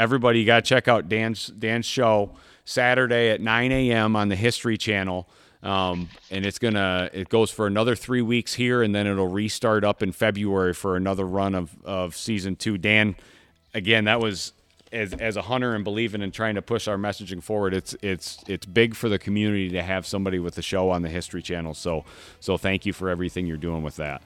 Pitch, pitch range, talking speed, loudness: 100 Hz, 95-110 Hz, 210 wpm, -24 LUFS